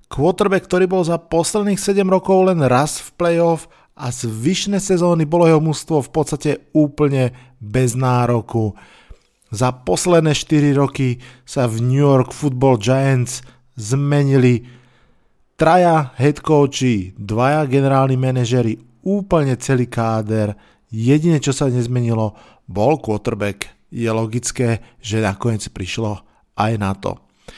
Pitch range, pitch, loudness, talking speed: 120-155 Hz, 130 Hz, -17 LUFS, 125 wpm